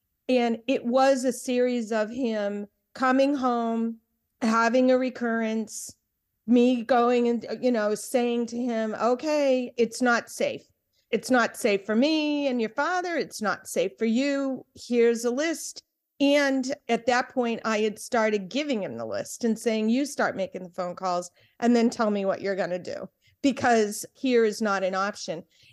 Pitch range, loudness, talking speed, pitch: 220-260 Hz, -26 LUFS, 175 wpm, 235 Hz